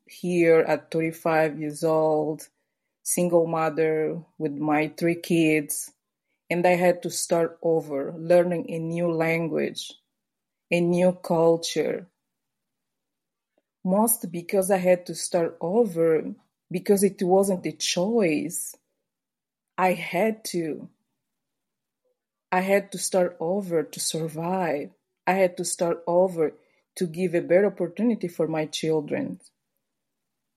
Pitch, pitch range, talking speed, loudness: 170 Hz, 160-185 Hz, 115 wpm, -24 LUFS